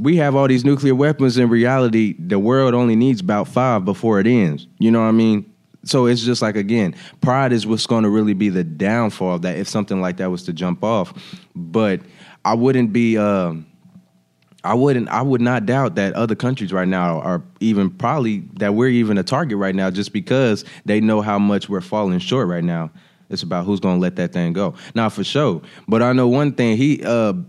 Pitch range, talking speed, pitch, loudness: 95-125 Hz, 225 wpm, 110 Hz, -18 LUFS